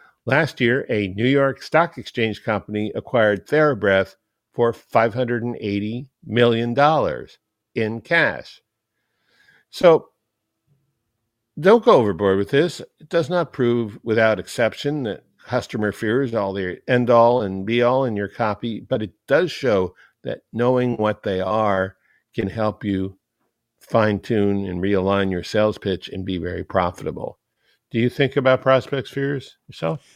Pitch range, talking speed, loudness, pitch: 100-125 Hz, 145 wpm, -20 LUFS, 115 Hz